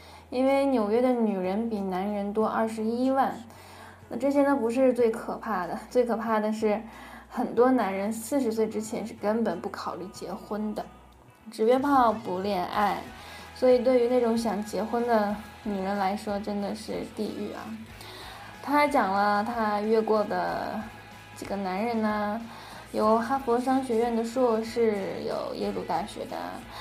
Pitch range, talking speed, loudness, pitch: 210-245 Hz, 230 characters per minute, -27 LUFS, 225 Hz